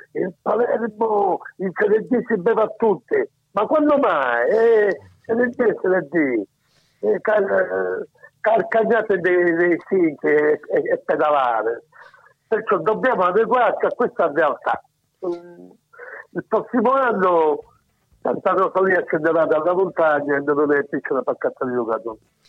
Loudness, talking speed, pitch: -20 LUFS, 125 wpm, 220 Hz